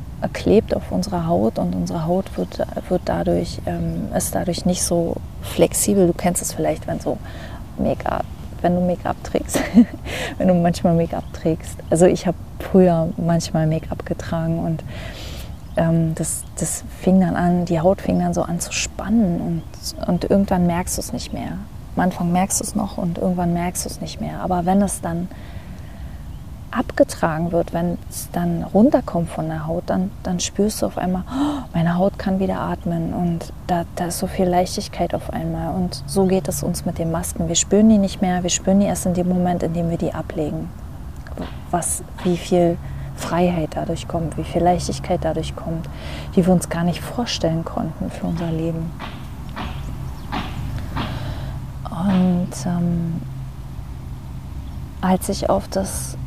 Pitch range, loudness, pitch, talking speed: 155-185 Hz, -21 LUFS, 170 Hz, 175 wpm